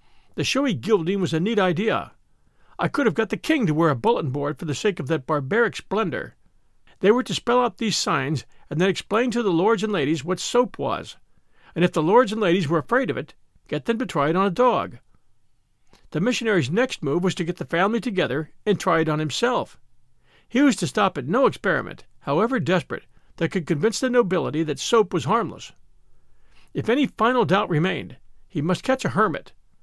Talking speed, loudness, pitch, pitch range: 210 wpm, -22 LUFS, 195 Hz, 165-230 Hz